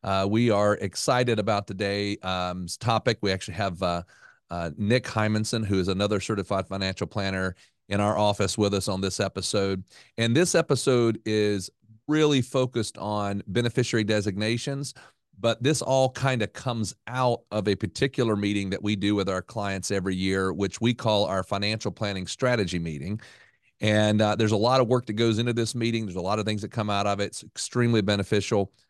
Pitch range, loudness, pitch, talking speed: 100-115 Hz, -26 LUFS, 105 Hz, 185 wpm